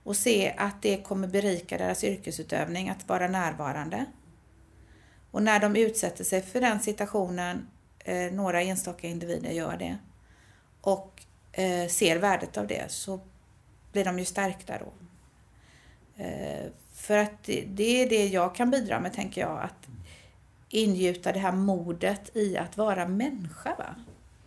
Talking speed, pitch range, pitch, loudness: 135 wpm, 180-210 Hz, 195 Hz, -29 LUFS